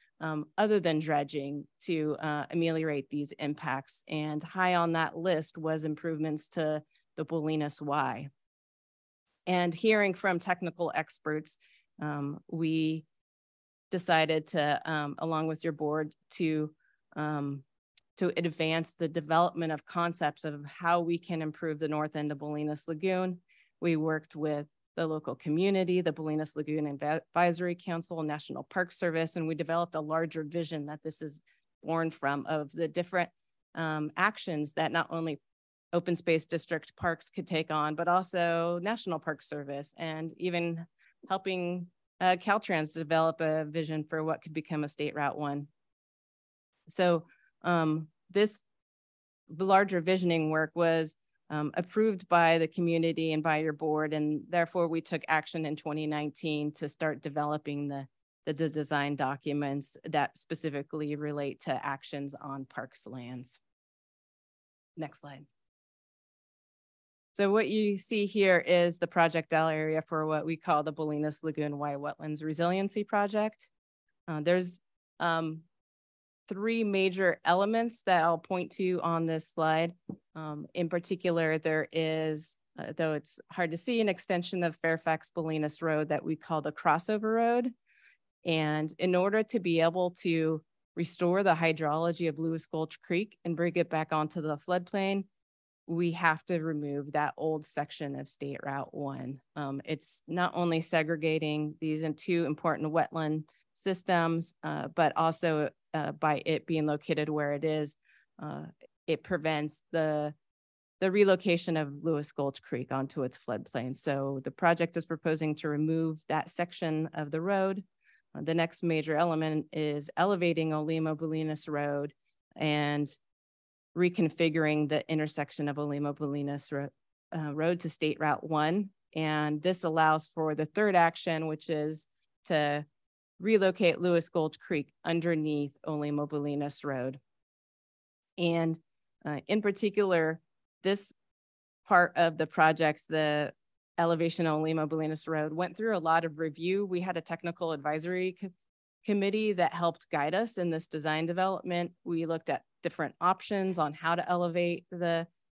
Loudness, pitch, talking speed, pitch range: -31 LUFS, 160 Hz, 145 wpm, 150-170 Hz